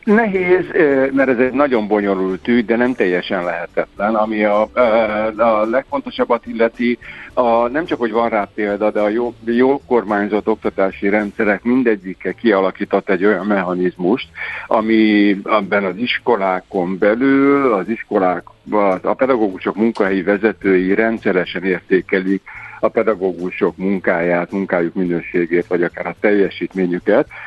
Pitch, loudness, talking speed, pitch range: 105 Hz, -17 LUFS, 125 wpm, 95-115 Hz